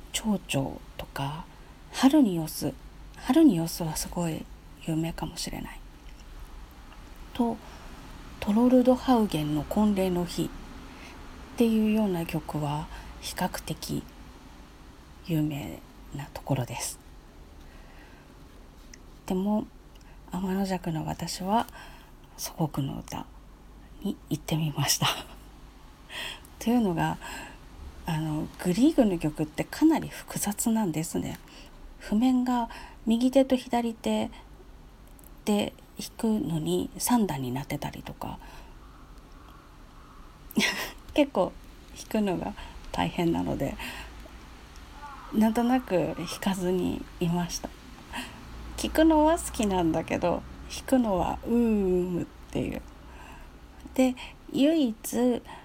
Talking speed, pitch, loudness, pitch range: 185 characters per minute, 190 Hz, -28 LUFS, 160-240 Hz